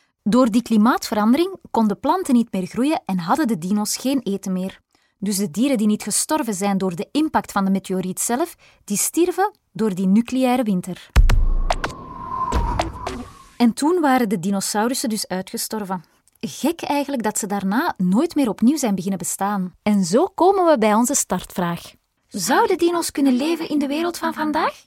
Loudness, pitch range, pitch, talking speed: -20 LUFS, 200-295 Hz, 230 Hz, 165 wpm